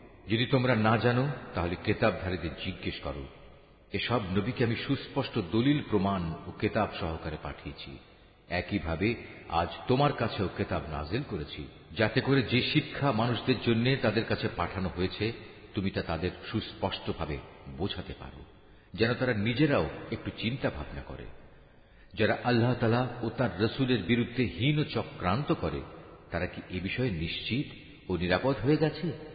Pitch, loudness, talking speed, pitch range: 105 Hz, -30 LUFS, 125 wpm, 90-125 Hz